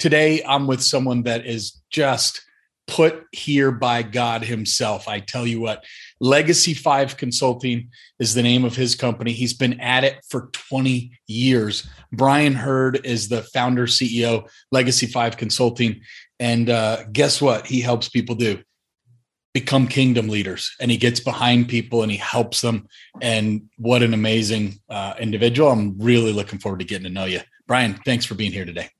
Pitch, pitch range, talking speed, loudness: 120 Hz, 110-130 Hz, 170 wpm, -20 LUFS